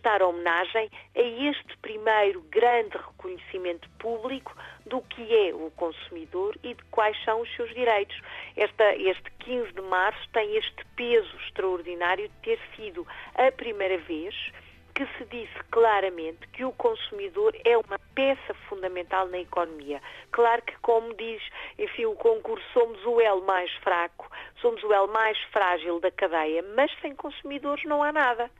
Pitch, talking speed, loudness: 235 Hz, 155 wpm, -27 LUFS